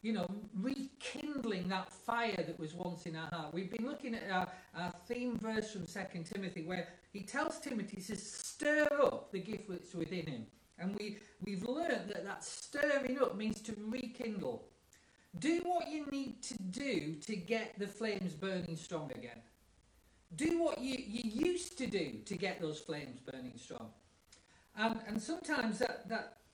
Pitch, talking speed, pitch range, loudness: 210 Hz, 170 wpm, 180-250 Hz, -40 LUFS